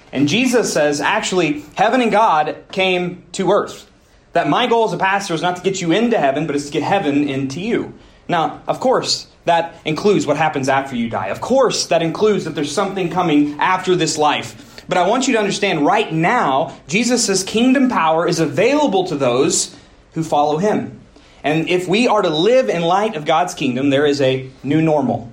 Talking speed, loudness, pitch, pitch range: 200 wpm, -17 LUFS, 170 Hz, 150-200 Hz